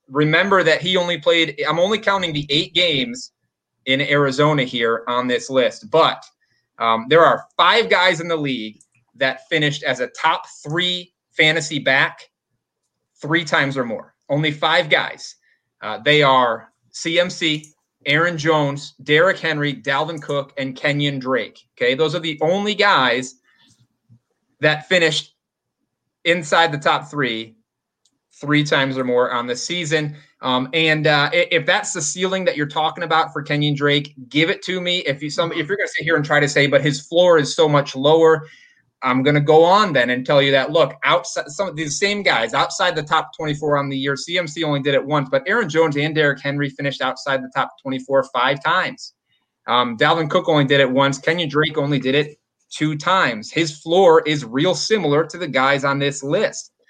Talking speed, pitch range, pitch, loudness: 190 wpm, 140-165 Hz, 150 Hz, -18 LUFS